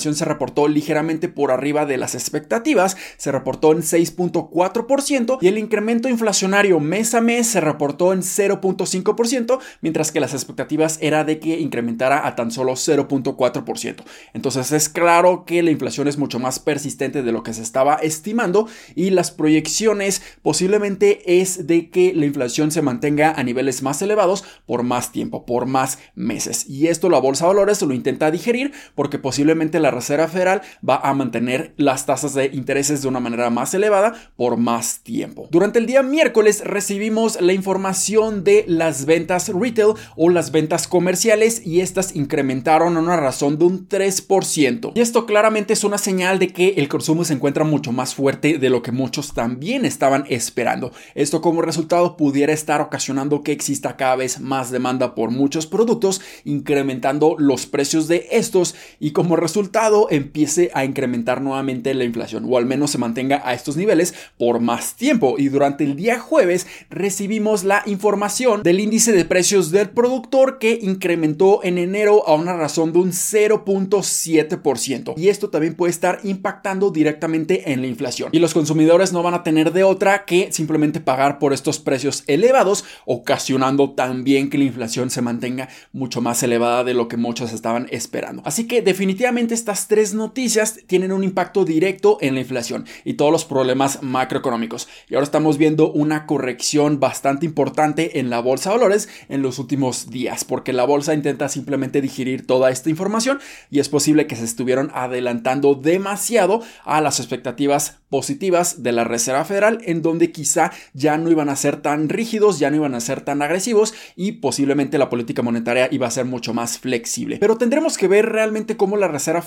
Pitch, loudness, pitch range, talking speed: 155 Hz, -18 LUFS, 135-190 Hz, 175 wpm